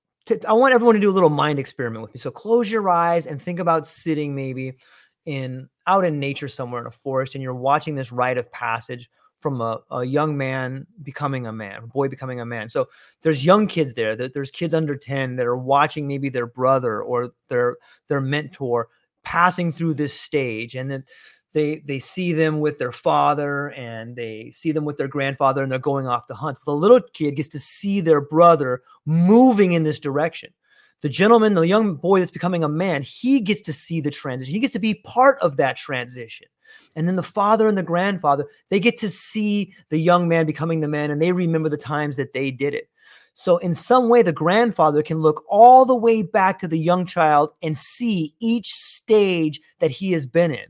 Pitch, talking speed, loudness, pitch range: 155 Hz, 210 wpm, -20 LUFS, 135-185 Hz